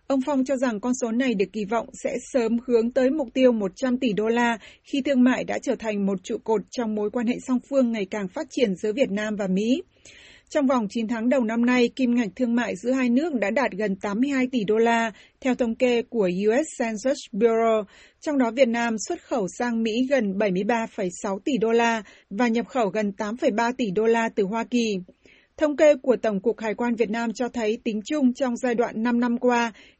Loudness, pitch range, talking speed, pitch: -24 LUFS, 220-255 Hz, 230 wpm, 235 Hz